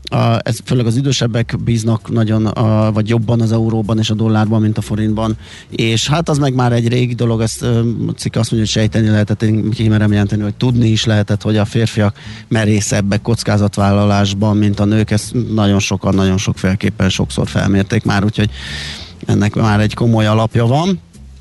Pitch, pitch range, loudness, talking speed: 110 Hz, 105-115 Hz, -15 LUFS, 175 wpm